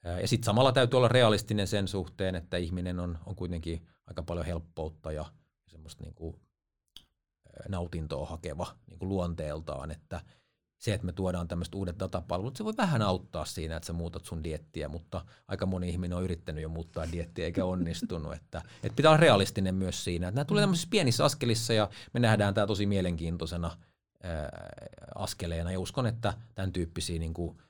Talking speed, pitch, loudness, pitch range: 170 wpm, 90 Hz, -31 LUFS, 85-105 Hz